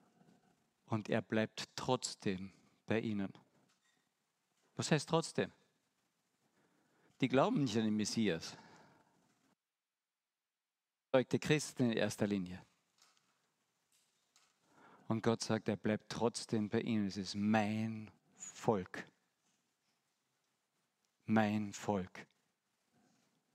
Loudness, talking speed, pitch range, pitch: -37 LUFS, 85 wpm, 105-130 Hz, 110 Hz